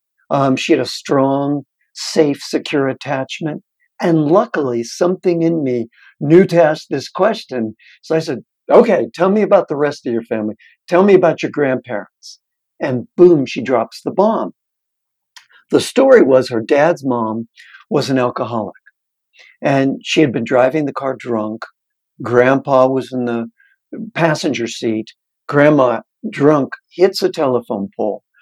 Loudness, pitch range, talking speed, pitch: -15 LUFS, 125-165 Hz, 150 wpm, 140 Hz